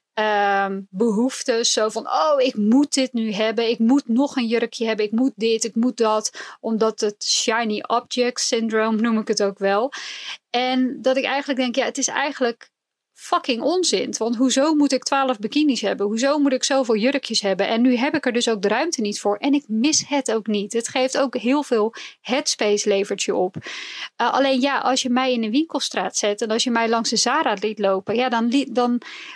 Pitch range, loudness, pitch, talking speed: 220-265 Hz, -20 LUFS, 240 Hz, 215 wpm